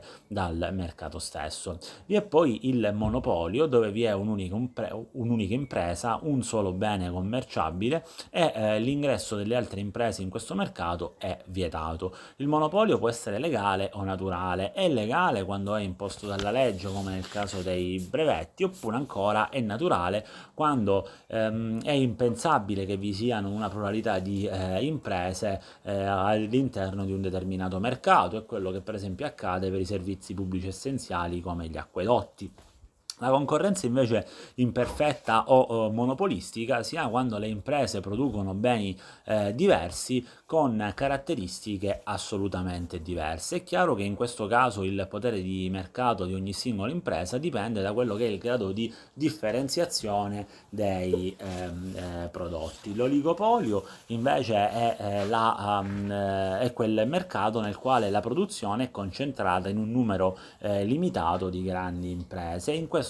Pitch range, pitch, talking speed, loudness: 95-120 Hz, 105 Hz, 150 wpm, -29 LUFS